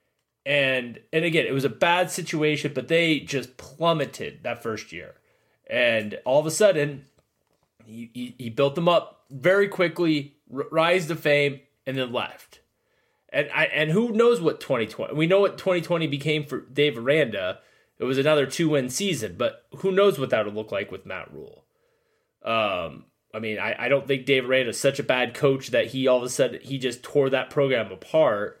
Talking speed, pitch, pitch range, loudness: 195 wpm, 145 Hz, 130-170 Hz, -24 LUFS